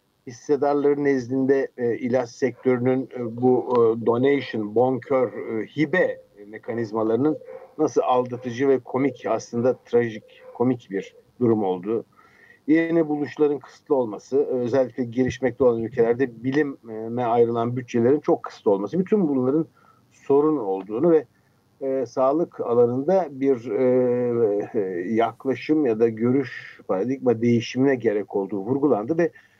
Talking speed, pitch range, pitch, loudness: 120 wpm, 120-140 Hz, 130 Hz, -23 LUFS